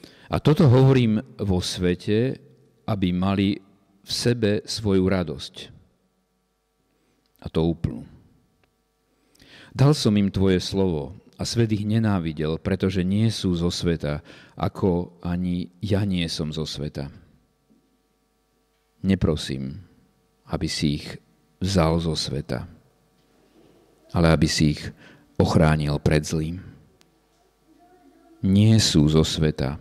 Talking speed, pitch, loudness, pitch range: 105 wpm, 90 Hz, -23 LUFS, 80-105 Hz